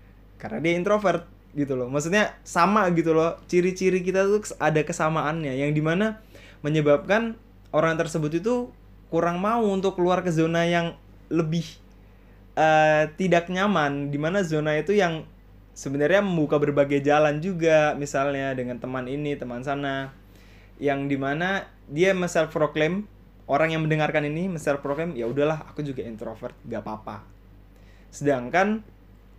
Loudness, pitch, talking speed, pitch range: -24 LUFS, 155 Hz, 130 wpm, 135-170 Hz